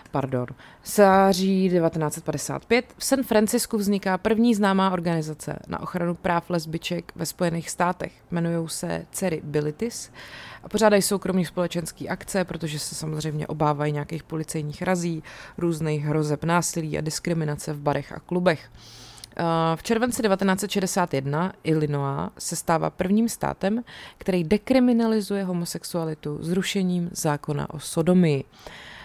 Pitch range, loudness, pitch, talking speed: 155-190 Hz, -24 LUFS, 170 Hz, 120 wpm